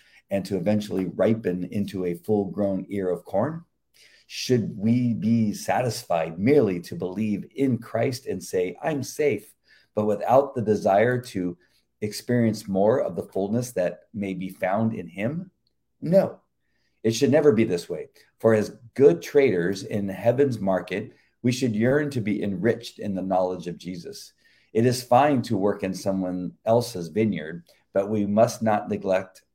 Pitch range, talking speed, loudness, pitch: 95-120 Hz, 160 wpm, -24 LUFS, 105 Hz